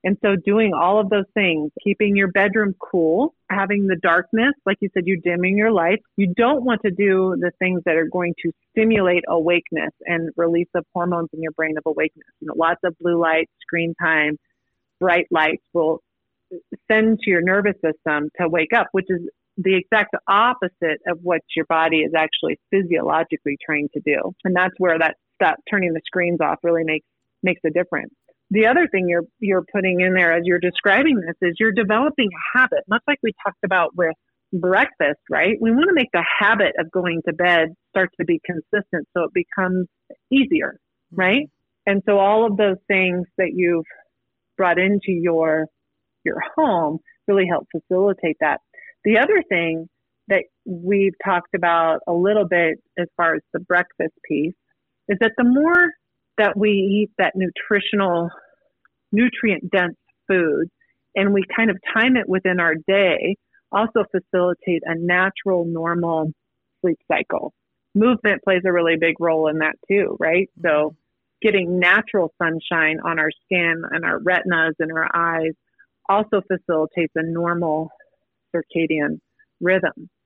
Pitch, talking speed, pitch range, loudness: 180 Hz, 170 wpm, 165-205 Hz, -19 LUFS